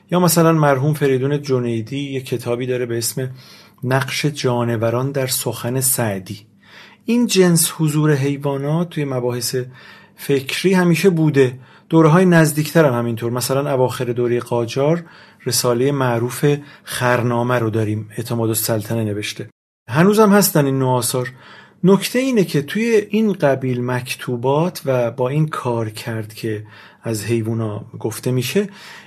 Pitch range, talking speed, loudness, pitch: 120-155 Hz, 130 wpm, -18 LUFS, 130 Hz